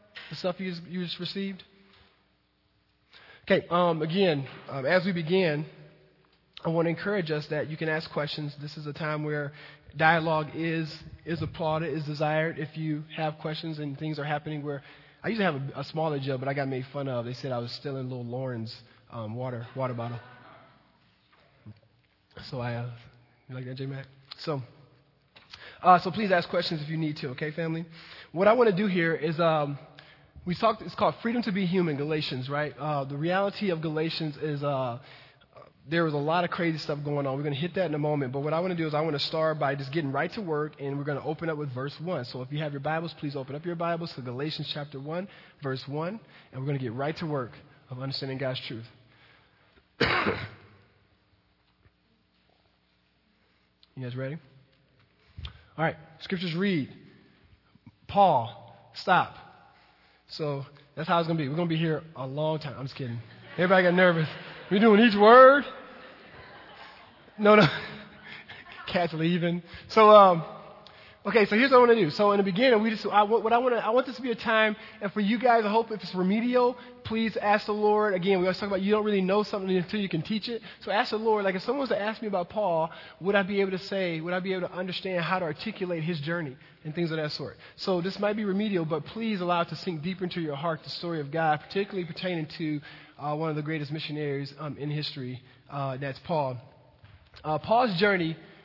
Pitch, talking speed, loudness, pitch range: 160 Hz, 210 wpm, -27 LUFS, 140-185 Hz